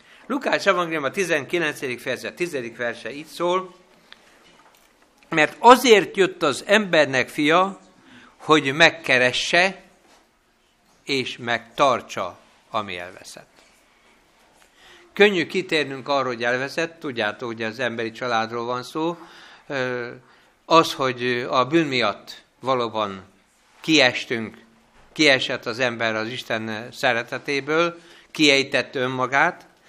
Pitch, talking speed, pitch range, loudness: 135 Hz, 100 wpm, 120-165 Hz, -21 LUFS